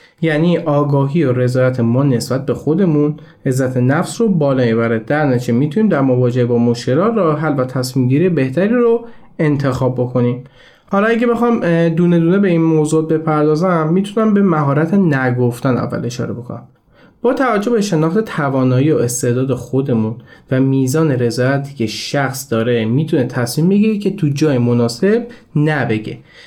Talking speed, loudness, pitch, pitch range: 150 wpm, -15 LUFS, 145 Hz, 125-170 Hz